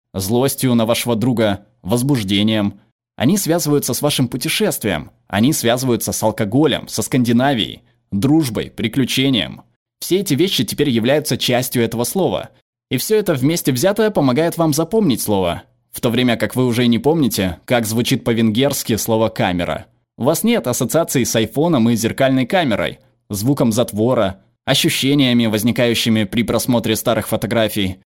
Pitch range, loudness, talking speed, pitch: 110-140 Hz, -17 LUFS, 140 wpm, 120 Hz